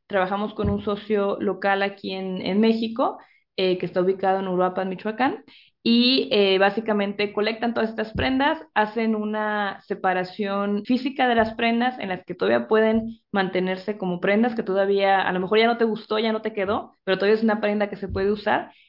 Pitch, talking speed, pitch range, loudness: 205 Hz, 195 wpm, 195-220 Hz, -23 LUFS